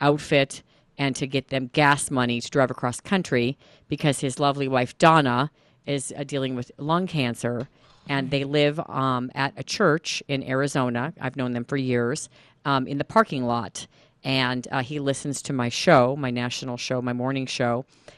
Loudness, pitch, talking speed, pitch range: -24 LUFS, 135 Hz, 180 wpm, 125-145 Hz